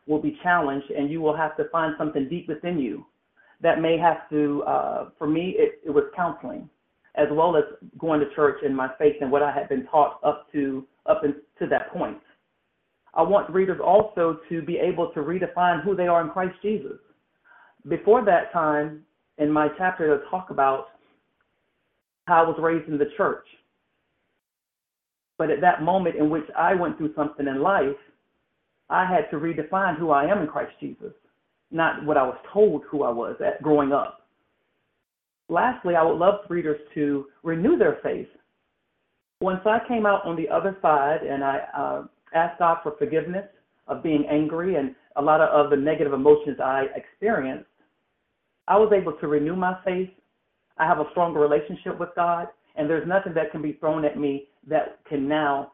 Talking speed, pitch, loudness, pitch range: 185 wpm, 160 Hz, -23 LUFS, 150-180 Hz